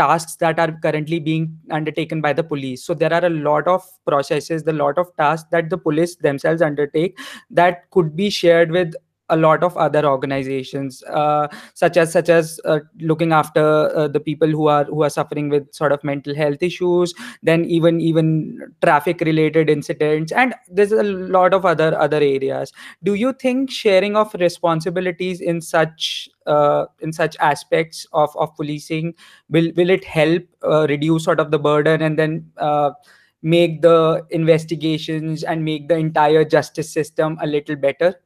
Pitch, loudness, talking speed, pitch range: 160 Hz, -18 LUFS, 175 wpm, 150-170 Hz